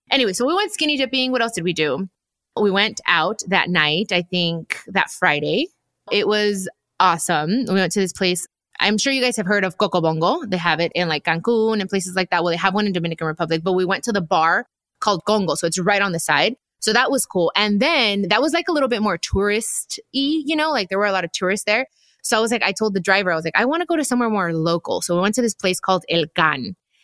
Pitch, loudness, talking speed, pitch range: 200 Hz, -19 LUFS, 265 wpm, 180-230 Hz